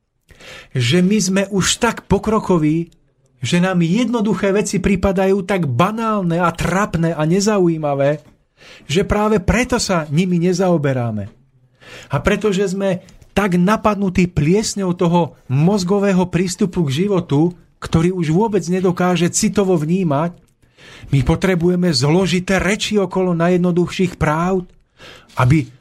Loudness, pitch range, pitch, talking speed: -17 LUFS, 160-195 Hz, 180 Hz, 110 wpm